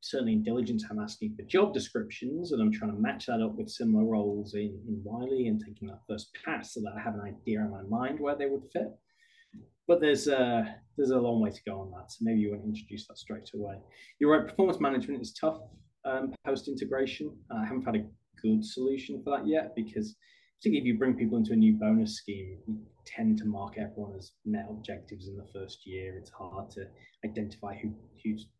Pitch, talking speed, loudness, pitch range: 115 Hz, 225 wpm, -31 LUFS, 105-175 Hz